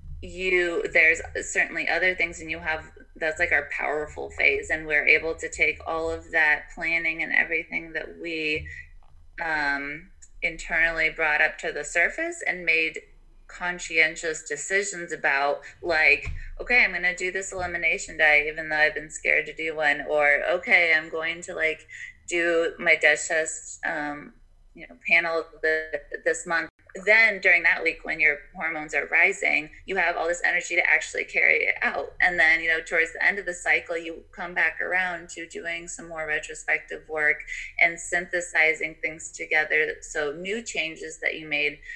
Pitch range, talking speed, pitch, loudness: 155-180 Hz, 175 wpm, 160 Hz, -23 LUFS